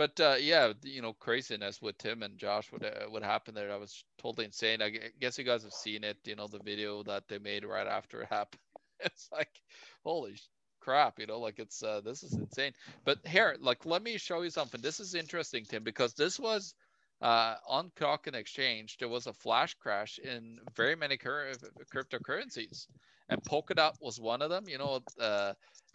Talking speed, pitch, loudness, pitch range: 200 wpm, 120 Hz, -34 LUFS, 105-155 Hz